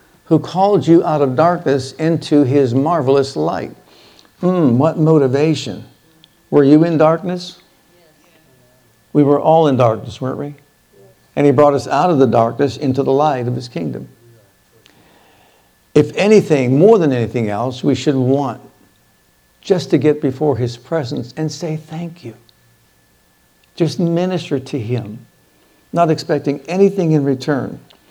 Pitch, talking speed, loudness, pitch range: 145 Hz, 140 wpm, -15 LUFS, 125-160 Hz